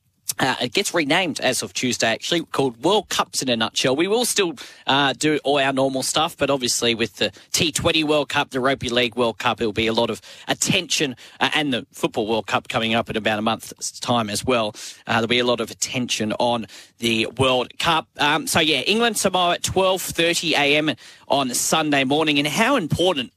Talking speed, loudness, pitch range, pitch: 215 wpm, -20 LUFS, 115-155 Hz, 130 Hz